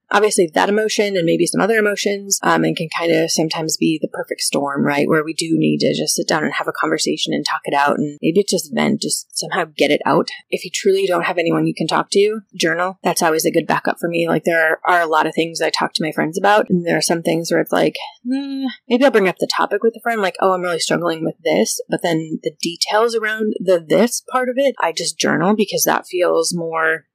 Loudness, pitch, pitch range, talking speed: -17 LUFS, 180 Hz, 165-215 Hz, 260 wpm